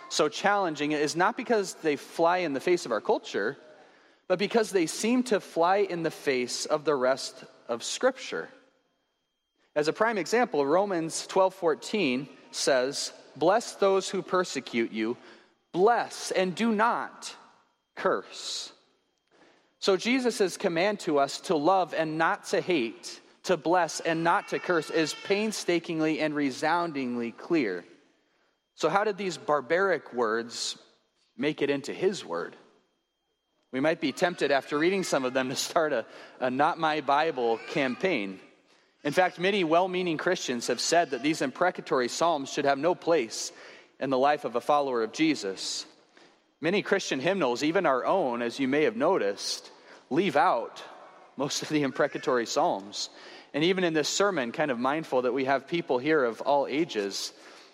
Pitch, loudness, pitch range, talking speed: 170 Hz, -28 LUFS, 145-200 Hz, 160 wpm